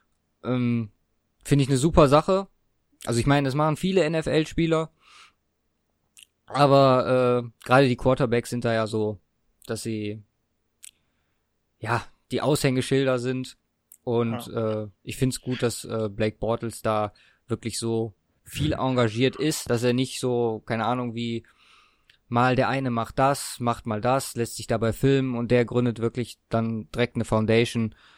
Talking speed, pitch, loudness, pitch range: 150 wpm, 120 Hz, -24 LUFS, 110-130 Hz